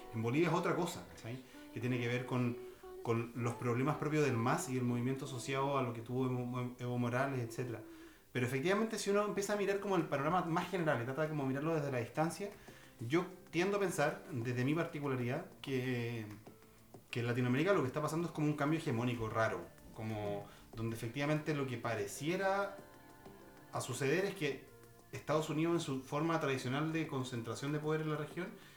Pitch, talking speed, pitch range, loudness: 135 Hz, 190 wpm, 120-165 Hz, -37 LUFS